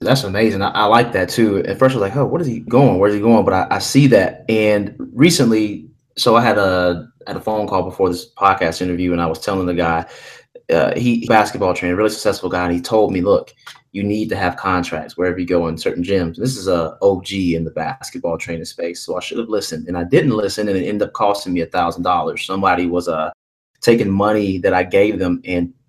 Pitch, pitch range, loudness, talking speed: 95 Hz, 90-110 Hz, -17 LUFS, 245 wpm